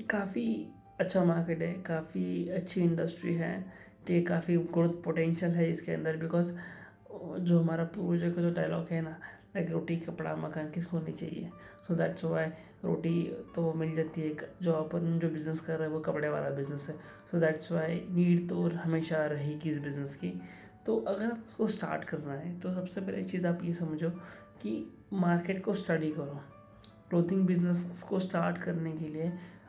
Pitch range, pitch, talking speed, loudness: 155-175 Hz, 165 Hz, 180 wpm, -33 LUFS